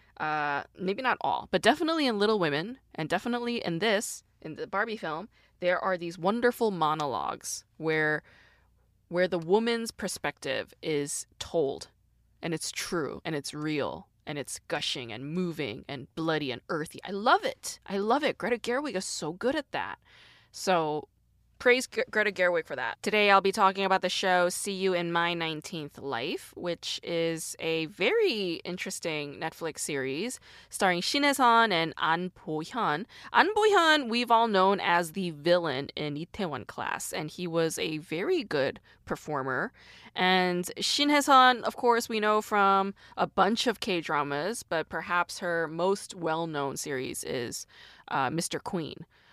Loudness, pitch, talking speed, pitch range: -28 LUFS, 180 Hz, 160 wpm, 160-220 Hz